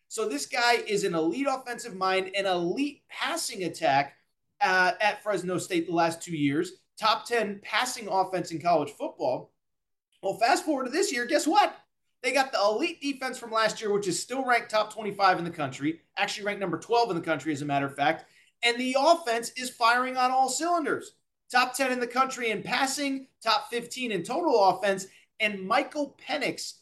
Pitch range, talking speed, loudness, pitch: 190-260 Hz, 195 wpm, -27 LUFS, 220 Hz